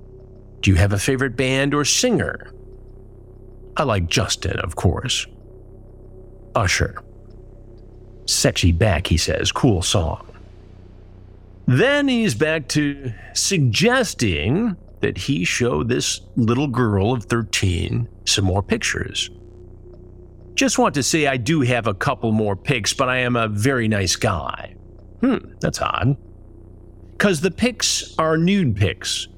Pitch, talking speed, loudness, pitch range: 115 Hz, 130 wpm, -20 LUFS, 95-135 Hz